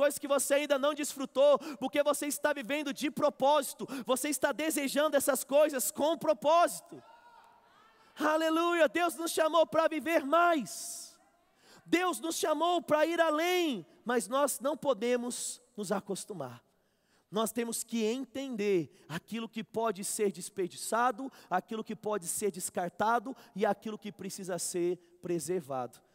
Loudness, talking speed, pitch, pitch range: -31 LUFS, 135 wpm, 270 Hz, 210-305 Hz